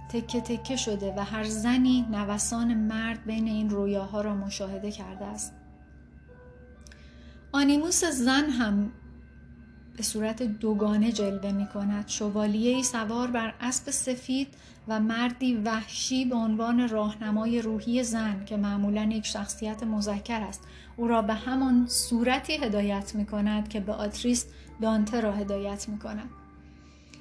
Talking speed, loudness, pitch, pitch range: 130 wpm, -28 LUFS, 215 Hz, 205-235 Hz